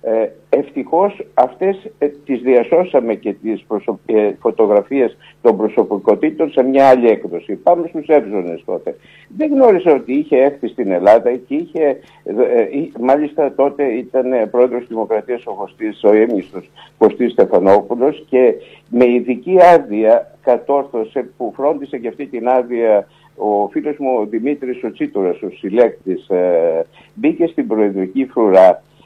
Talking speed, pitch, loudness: 130 wpm, 145 Hz, -15 LUFS